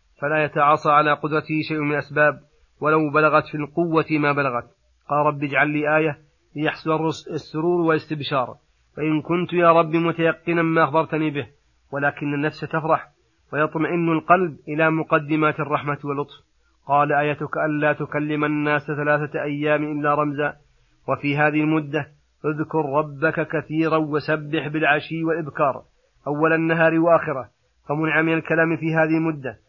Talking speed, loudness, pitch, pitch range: 130 wpm, -21 LUFS, 155 Hz, 145-160 Hz